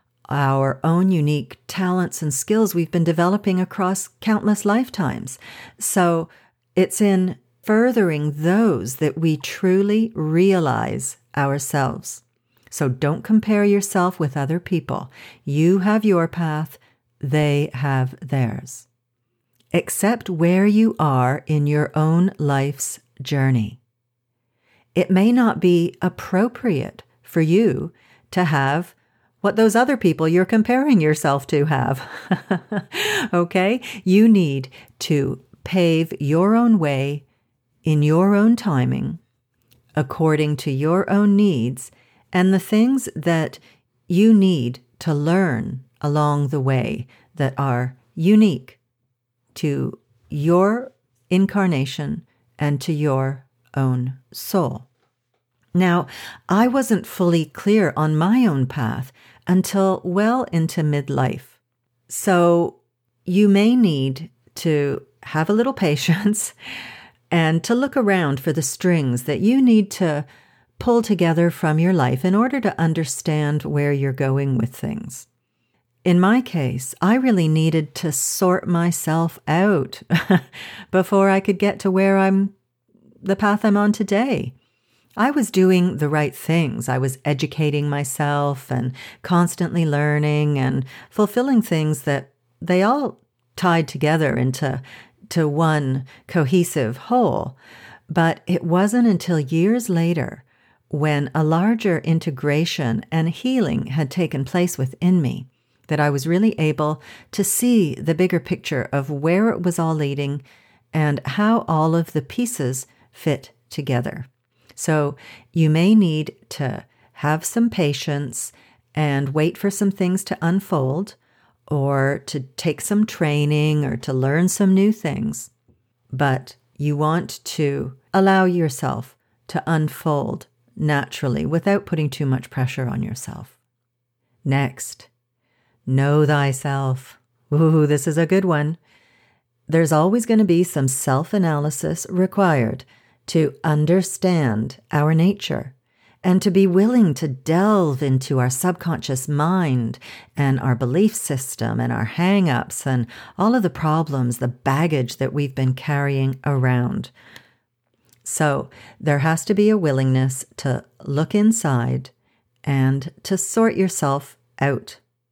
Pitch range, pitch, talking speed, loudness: 130-185 Hz, 155 Hz, 125 wpm, -20 LUFS